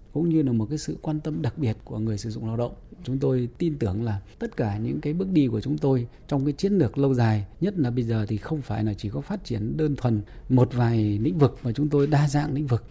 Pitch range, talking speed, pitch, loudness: 110-150 Hz, 285 wpm, 130 Hz, -25 LUFS